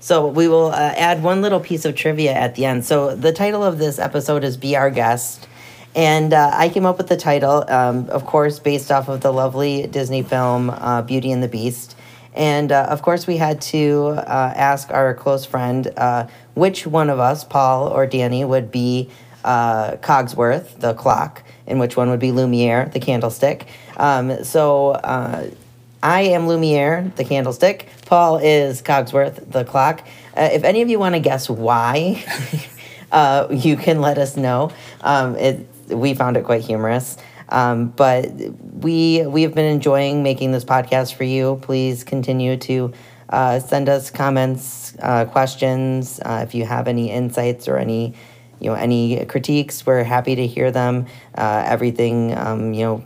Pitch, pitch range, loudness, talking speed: 130 Hz, 125-145 Hz, -18 LUFS, 180 wpm